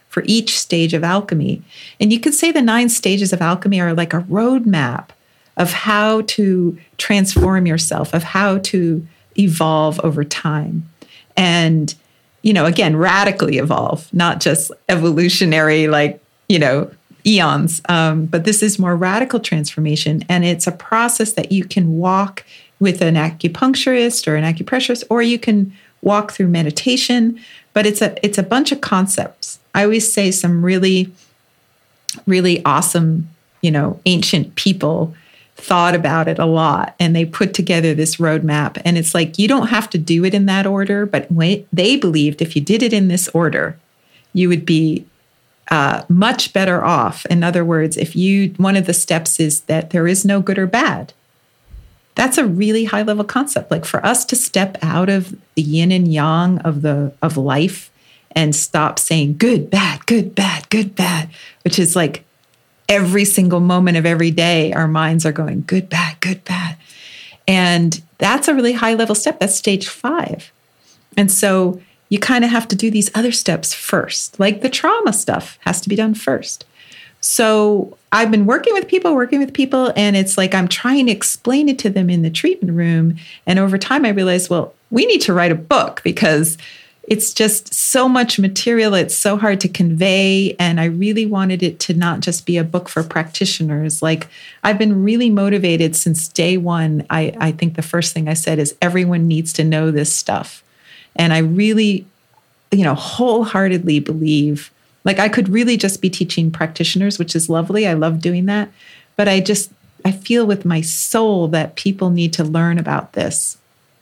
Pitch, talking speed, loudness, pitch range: 180 Hz, 175 wpm, -15 LUFS, 165-205 Hz